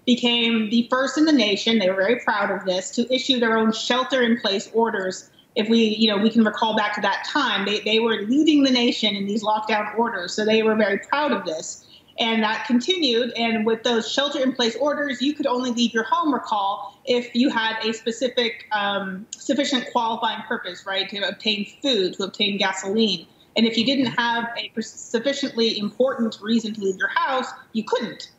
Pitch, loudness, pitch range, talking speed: 230 Hz, -22 LUFS, 215-250 Hz, 205 wpm